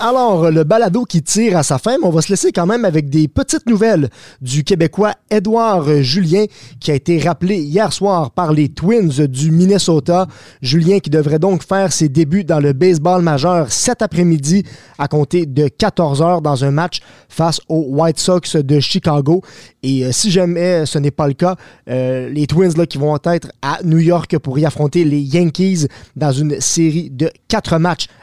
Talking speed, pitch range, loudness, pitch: 195 wpm, 150-185 Hz, -14 LUFS, 165 Hz